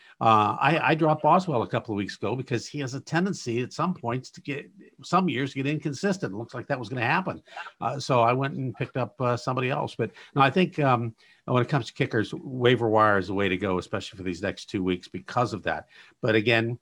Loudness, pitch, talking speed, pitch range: -26 LUFS, 125 Hz, 250 wpm, 115-145 Hz